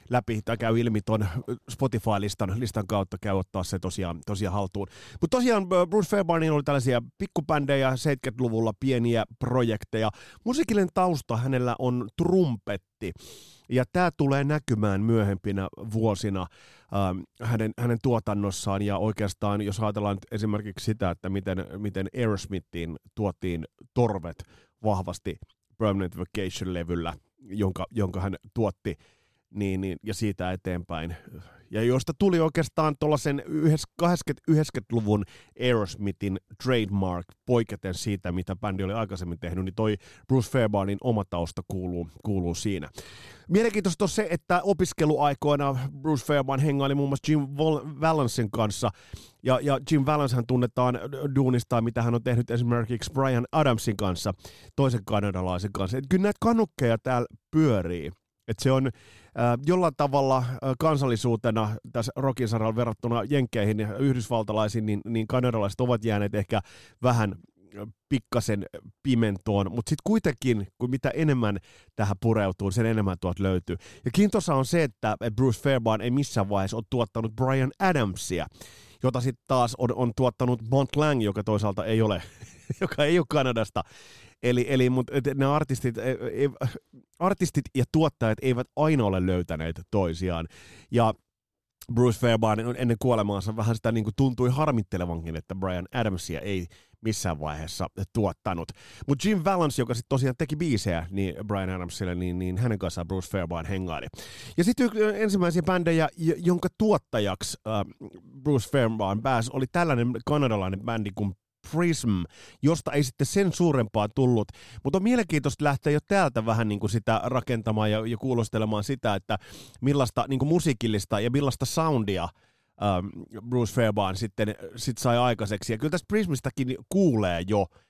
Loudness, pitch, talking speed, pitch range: -27 LUFS, 115 Hz, 140 wpm, 100-135 Hz